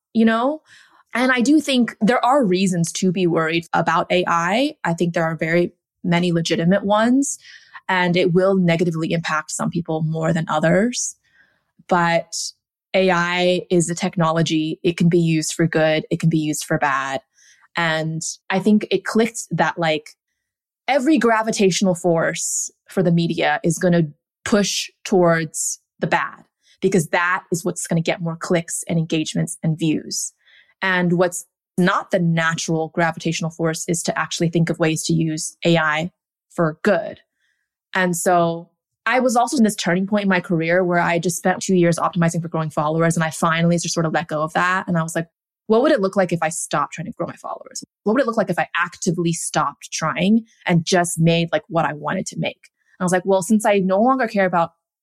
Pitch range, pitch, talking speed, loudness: 165-190 Hz, 175 Hz, 195 wpm, -19 LUFS